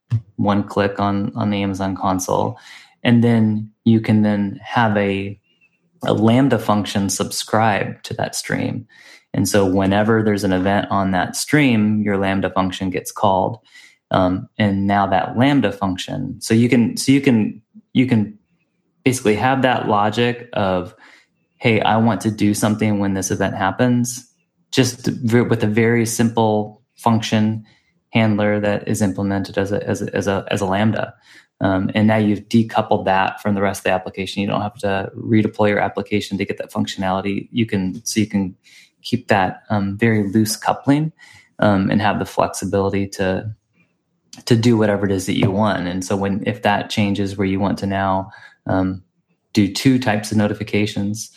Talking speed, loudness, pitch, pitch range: 175 wpm, -19 LUFS, 105 Hz, 100-115 Hz